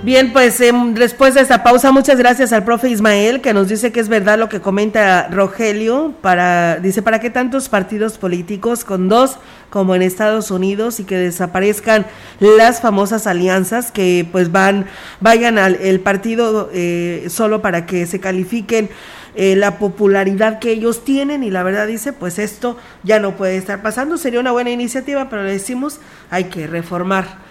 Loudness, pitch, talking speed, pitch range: -14 LUFS, 215 Hz, 175 wpm, 190-240 Hz